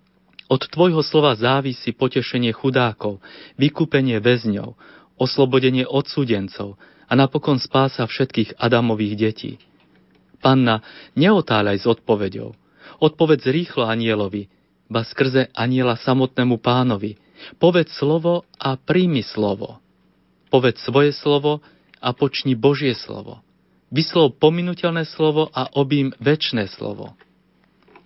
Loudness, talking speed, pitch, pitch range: -19 LUFS, 100 wpm, 130 Hz, 115-145 Hz